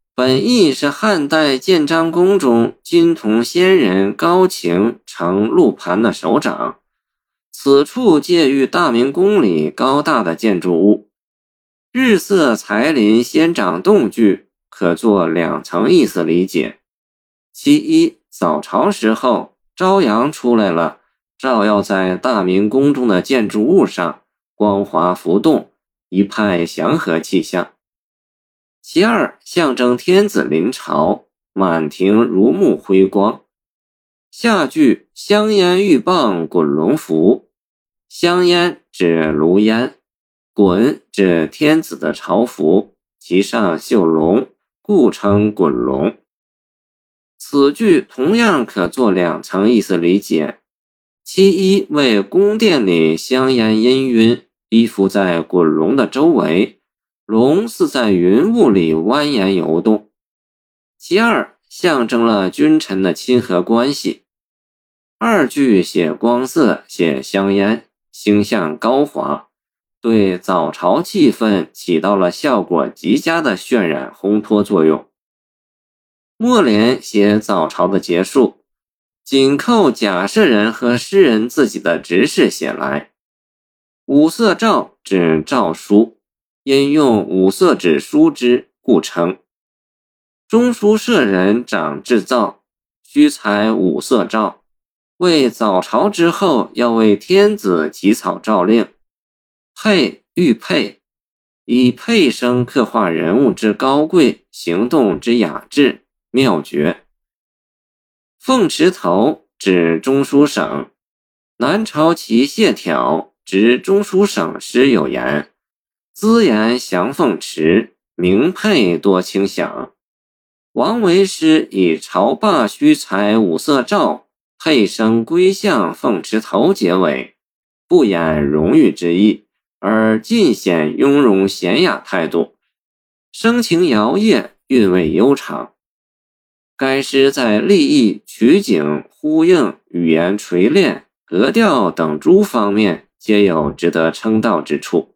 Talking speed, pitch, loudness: 160 characters per minute, 115 Hz, -14 LUFS